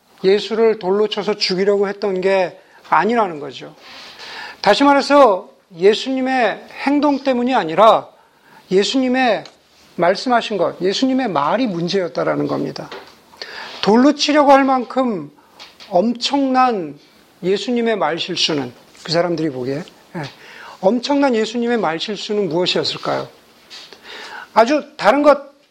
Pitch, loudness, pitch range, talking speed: 230 Hz, -17 LUFS, 190-280 Hz, 260 characters per minute